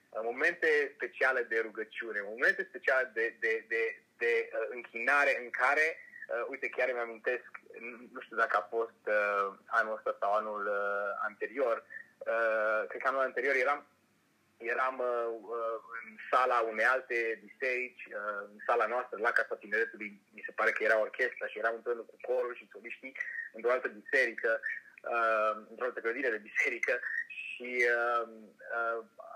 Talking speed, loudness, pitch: 155 wpm, -32 LUFS, 125 Hz